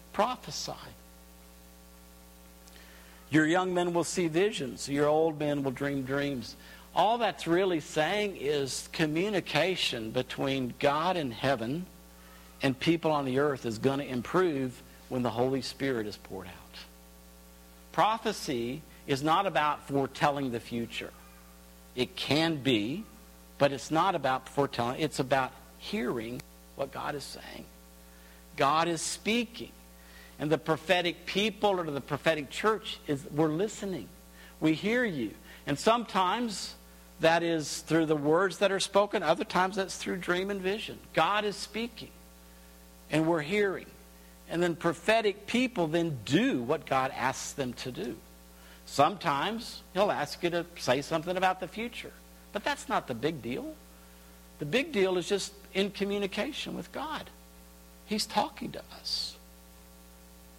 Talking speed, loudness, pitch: 140 wpm, -30 LUFS, 145 Hz